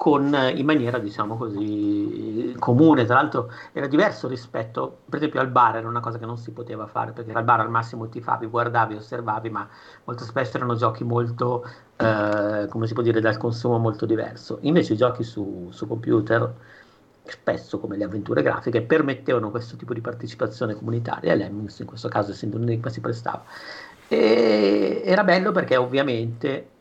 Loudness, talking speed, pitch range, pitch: -23 LUFS, 170 wpm, 110-120 Hz, 115 Hz